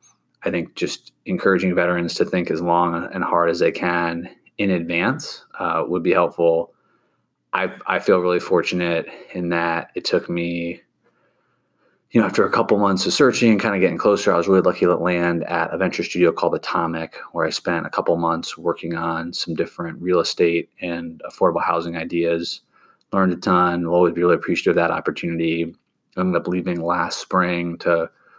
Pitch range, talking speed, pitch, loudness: 85-90 Hz, 190 wpm, 85 Hz, -20 LUFS